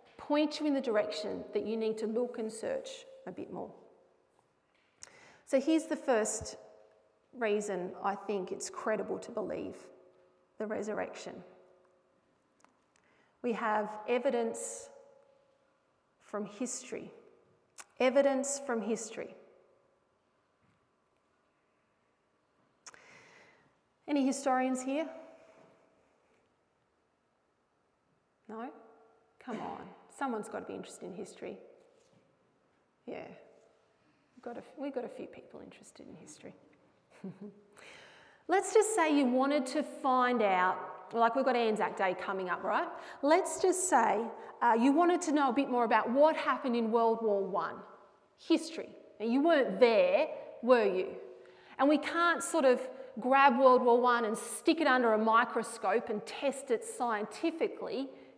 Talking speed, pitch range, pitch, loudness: 125 wpm, 220-310 Hz, 260 Hz, -31 LUFS